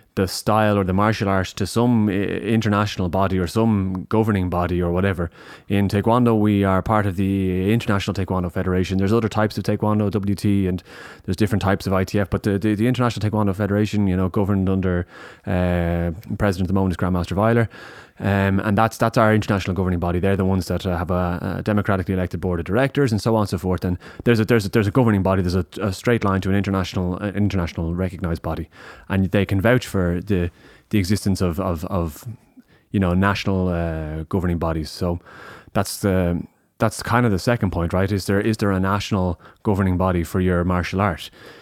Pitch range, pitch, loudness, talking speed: 90-105 Hz, 95 Hz, -21 LUFS, 210 wpm